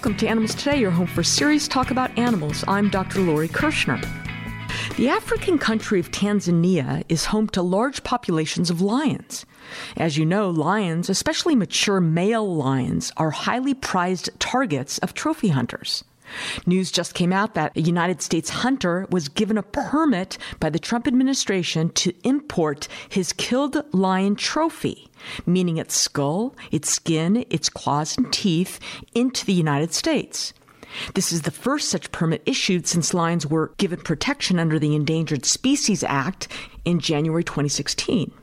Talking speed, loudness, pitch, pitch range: 155 wpm, -22 LUFS, 185 Hz, 165-230 Hz